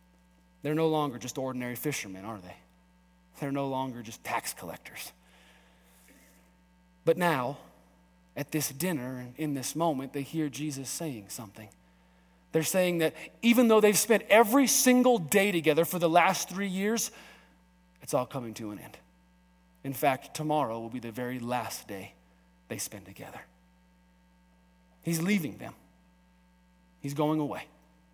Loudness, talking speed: -29 LUFS, 145 wpm